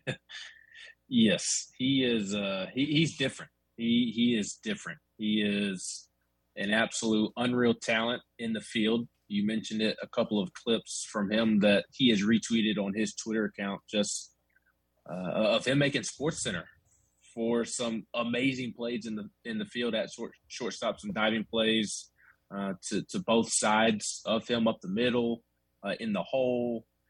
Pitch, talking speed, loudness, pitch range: 110 Hz, 160 wpm, -30 LUFS, 100-120 Hz